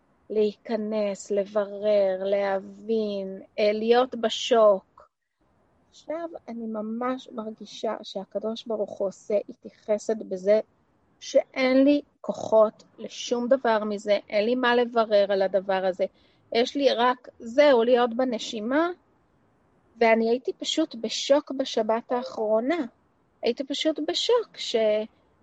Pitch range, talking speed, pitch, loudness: 210-260 Hz, 105 wpm, 225 Hz, -25 LUFS